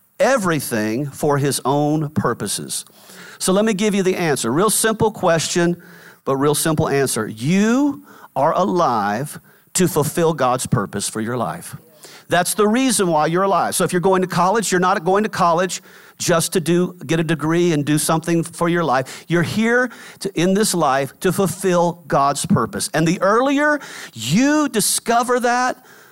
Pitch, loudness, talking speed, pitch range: 175 Hz, -18 LUFS, 170 wpm, 155-205 Hz